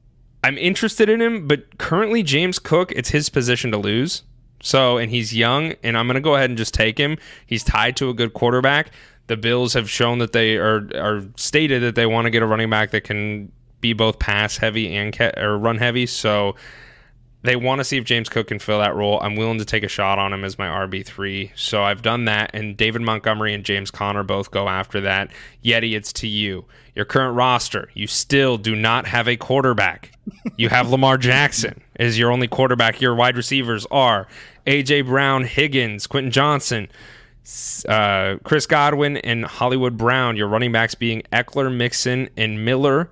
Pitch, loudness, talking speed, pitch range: 120 Hz, -19 LUFS, 200 wpm, 110-130 Hz